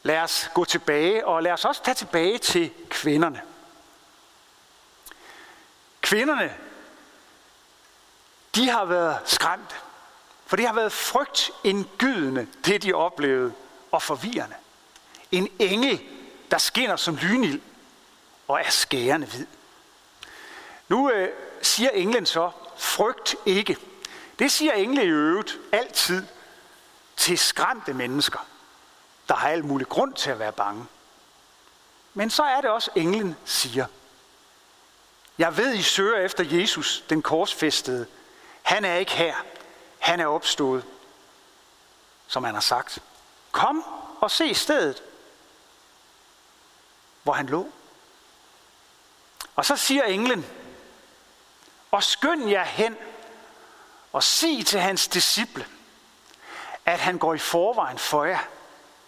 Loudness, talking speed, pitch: -23 LUFS, 120 wpm, 225 Hz